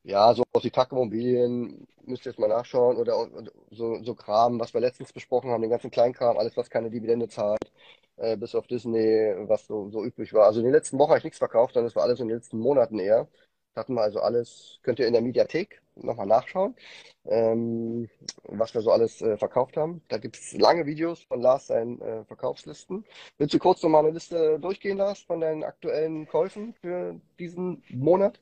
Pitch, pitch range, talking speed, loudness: 140 Hz, 120-190 Hz, 205 wpm, -25 LUFS